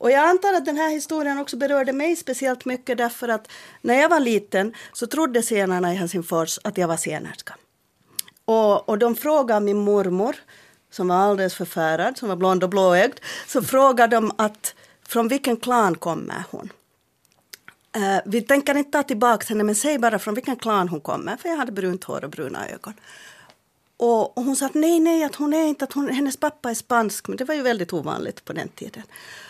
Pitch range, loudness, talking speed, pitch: 205-280 Hz, -22 LUFS, 200 wpm, 235 Hz